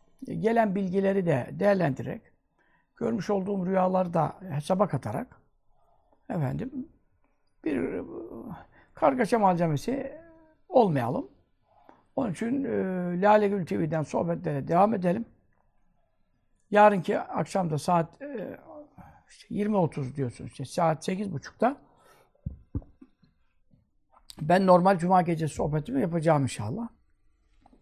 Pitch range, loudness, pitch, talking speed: 165-220 Hz, -27 LUFS, 190 Hz, 90 wpm